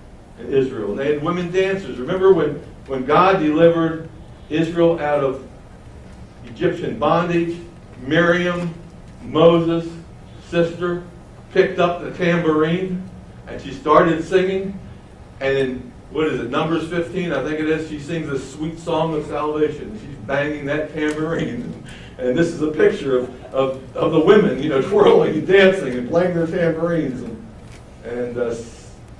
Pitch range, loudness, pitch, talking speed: 135-170 Hz, -19 LUFS, 160 Hz, 145 wpm